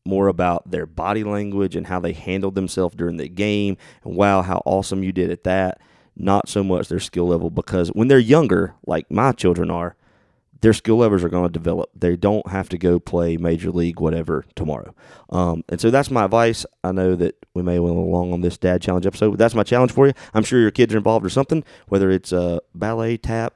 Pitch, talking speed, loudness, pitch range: 95 Hz, 230 wpm, -20 LUFS, 90-110 Hz